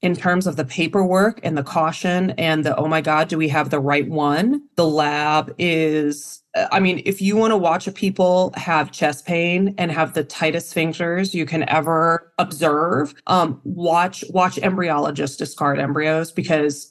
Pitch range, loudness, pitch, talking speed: 155-180 Hz, -19 LUFS, 165 Hz, 175 wpm